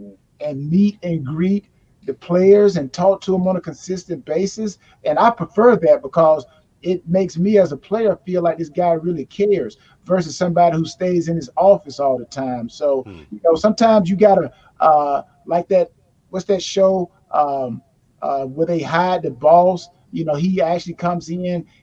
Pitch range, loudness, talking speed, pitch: 150-190 Hz, -18 LUFS, 185 wpm, 175 Hz